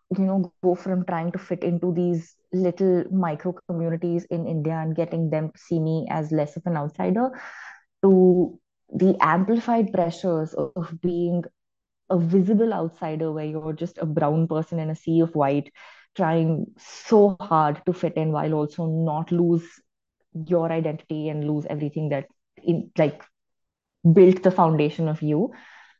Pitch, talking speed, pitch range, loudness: 170 Hz, 155 wpm, 155-180 Hz, -23 LUFS